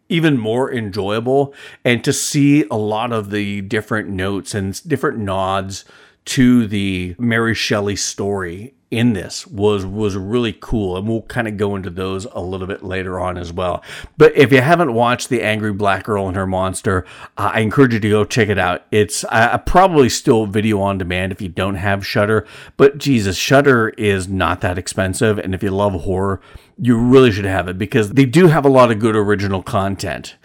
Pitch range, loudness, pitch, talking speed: 95-120 Hz, -16 LUFS, 105 Hz, 195 wpm